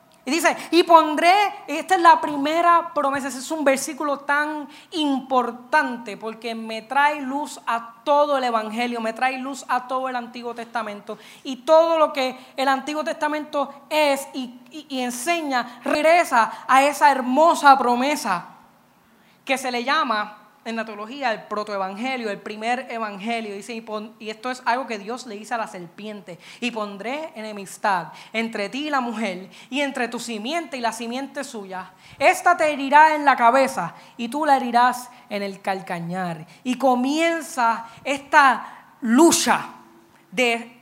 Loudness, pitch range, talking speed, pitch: -21 LUFS, 225-290 Hz, 160 wpm, 255 Hz